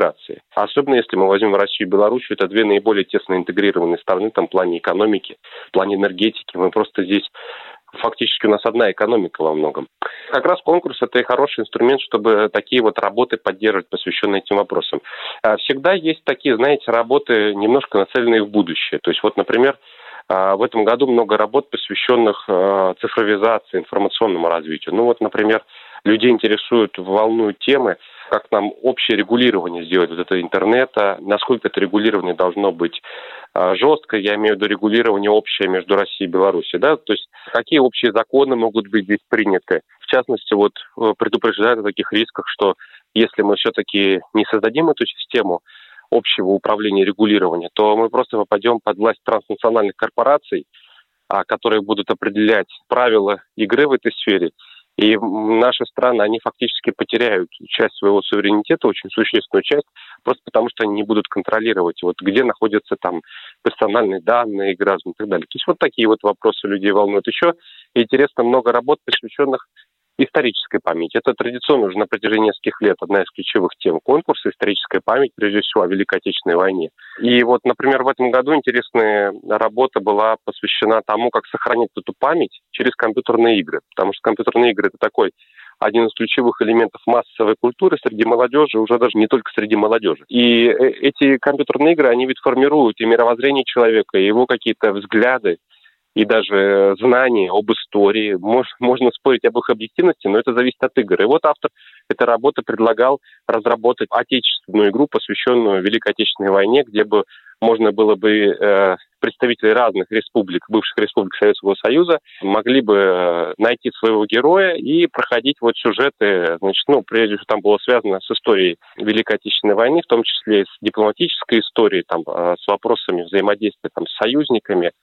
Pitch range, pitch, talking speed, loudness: 105-125 Hz, 110 Hz, 160 wpm, -17 LUFS